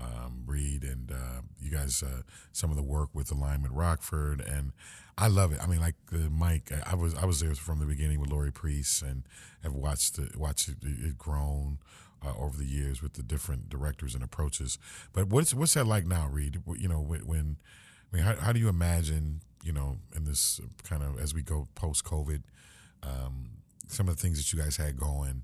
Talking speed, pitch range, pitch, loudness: 220 wpm, 70-85 Hz, 75 Hz, -32 LUFS